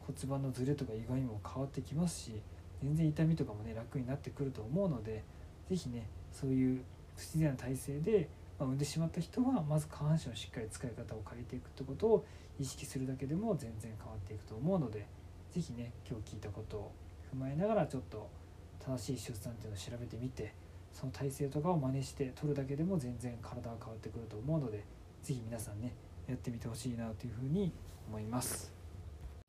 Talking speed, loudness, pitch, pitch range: 415 characters per minute, -39 LUFS, 125 Hz, 105-140 Hz